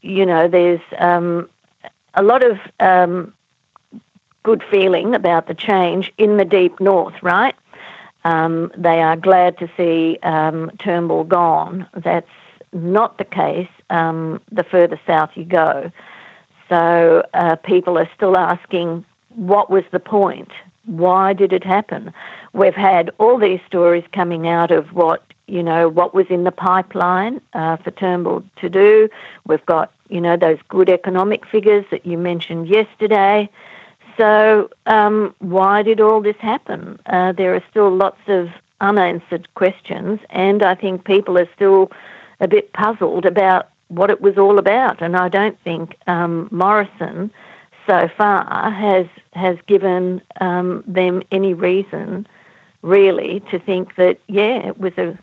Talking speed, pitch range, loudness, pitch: 150 wpm, 175-200 Hz, -16 LUFS, 185 Hz